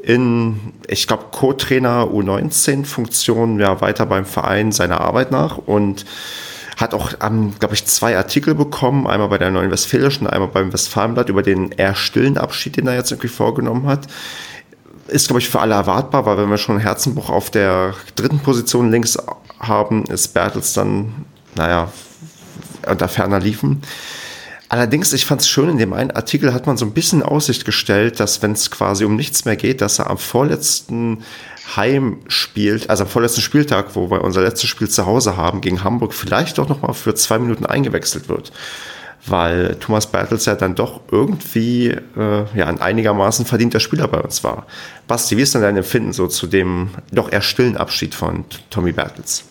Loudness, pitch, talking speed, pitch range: -16 LUFS, 110 Hz, 175 wpm, 100-125 Hz